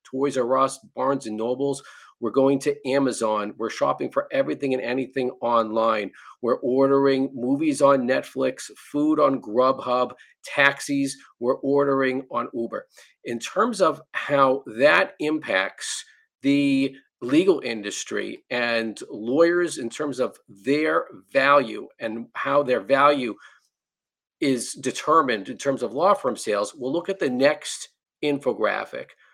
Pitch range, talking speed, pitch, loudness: 125-150 Hz, 130 wpm, 135 Hz, -23 LUFS